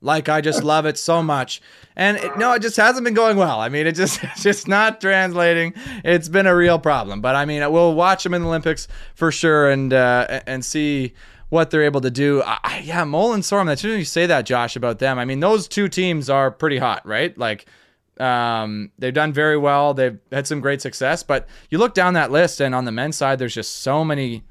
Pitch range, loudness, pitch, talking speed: 135-175 Hz, -18 LUFS, 155 Hz, 240 wpm